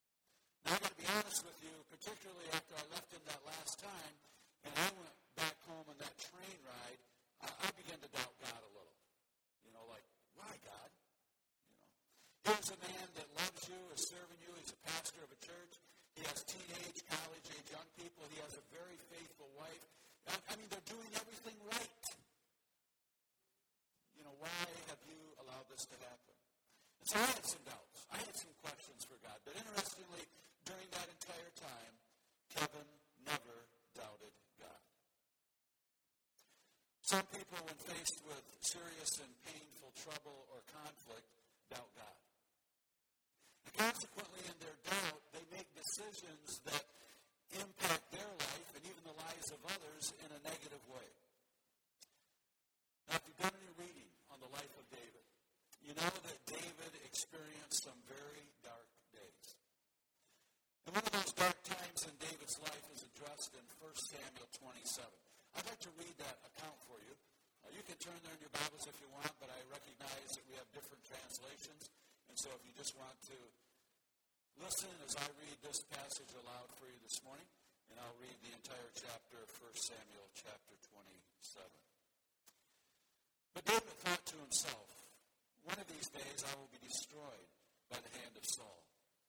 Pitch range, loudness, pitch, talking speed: 145-180 Hz, -46 LUFS, 160 Hz, 165 wpm